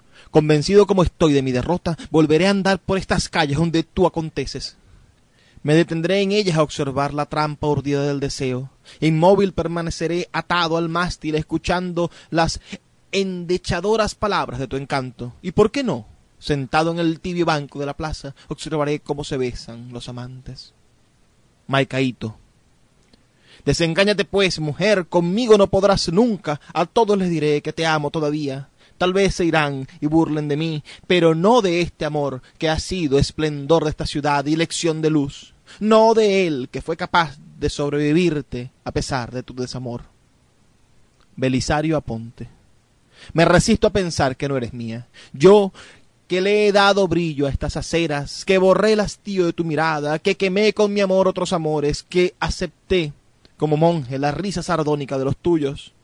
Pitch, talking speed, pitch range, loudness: 155 Hz, 165 wpm, 140-180 Hz, -20 LUFS